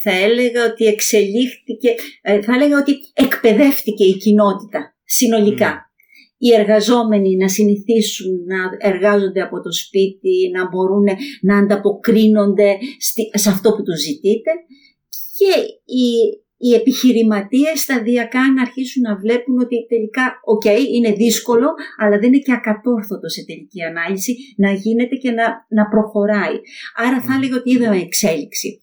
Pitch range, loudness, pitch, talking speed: 205-255 Hz, -15 LUFS, 225 Hz, 130 wpm